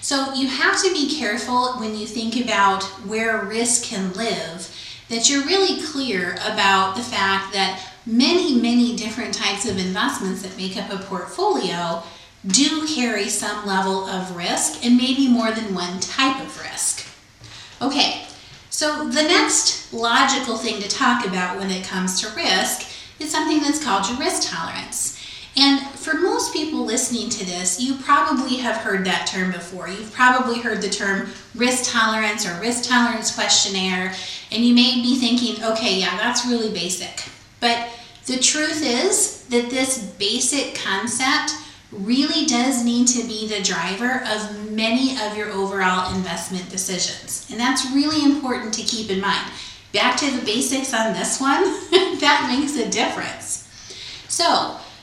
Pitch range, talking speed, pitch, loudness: 200-265 Hz, 160 wpm, 230 Hz, -20 LUFS